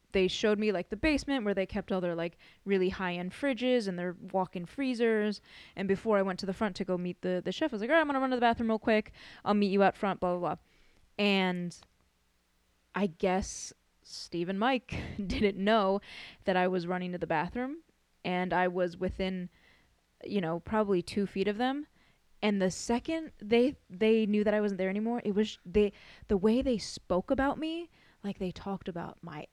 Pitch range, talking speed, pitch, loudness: 180-220 Hz, 215 wpm, 195 Hz, -31 LUFS